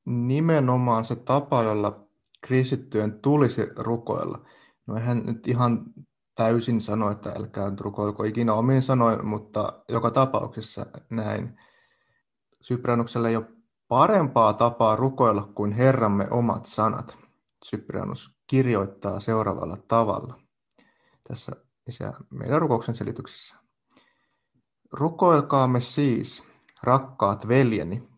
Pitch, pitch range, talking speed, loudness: 115 Hz, 105-130 Hz, 100 wpm, -24 LUFS